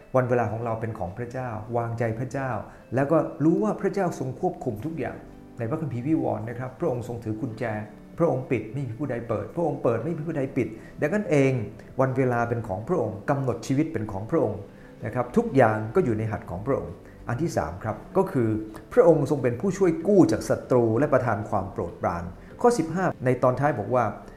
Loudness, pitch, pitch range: -26 LUFS, 125 Hz, 110-150 Hz